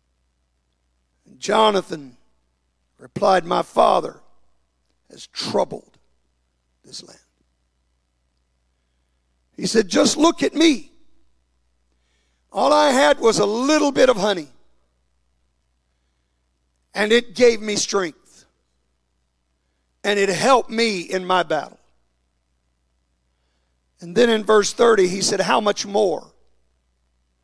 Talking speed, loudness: 100 wpm, -18 LUFS